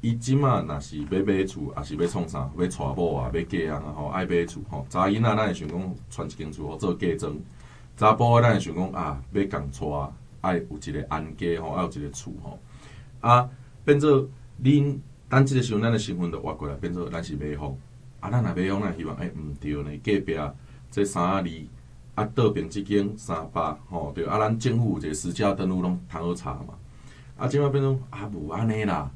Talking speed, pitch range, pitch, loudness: 285 characters per minute, 80-125 Hz, 100 Hz, -26 LUFS